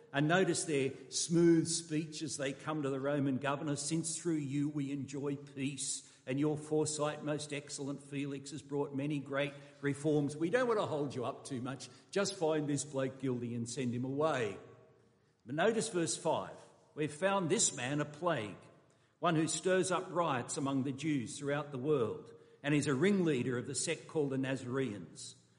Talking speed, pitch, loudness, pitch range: 185 wpm, 145 Hz, -35 LUFS, 135-160 Hz